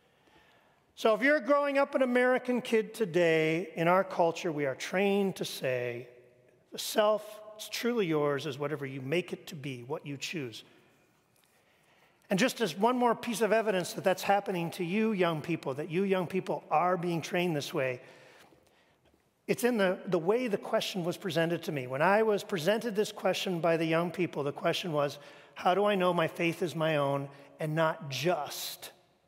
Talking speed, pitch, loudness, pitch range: 190 wpm, 180 Hz, -30 LUFS, 160-210 Hz